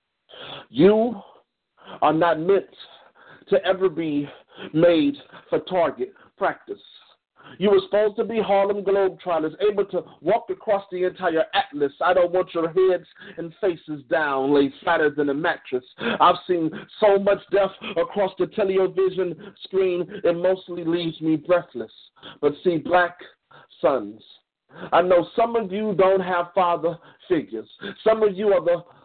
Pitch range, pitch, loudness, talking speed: 170-200 Hz, 185 Hz, -22 LUFS, 145 wpm